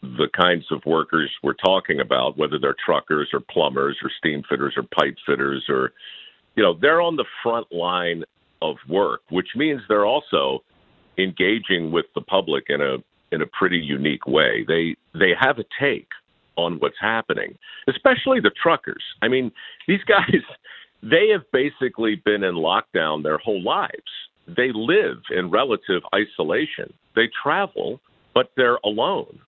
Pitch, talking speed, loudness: 105 Hz, 155 wpm, -21 LUFS